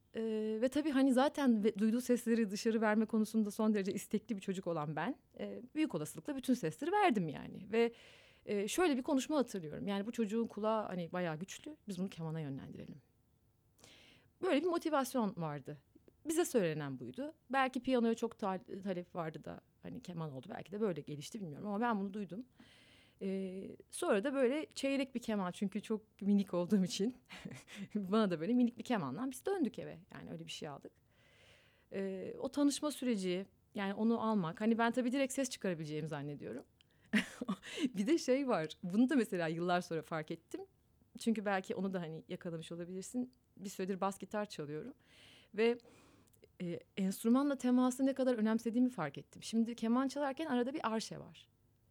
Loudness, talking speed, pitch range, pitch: -37 LUFS, 165 wpm, 185-250 Hz, 220 Hz